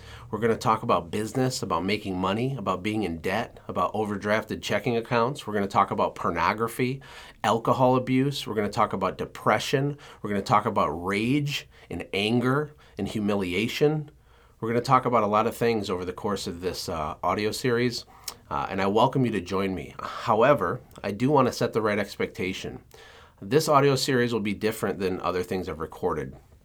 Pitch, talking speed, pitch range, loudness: 115 Hz, 195 wpm, 105-130 Hz, -26 LUFS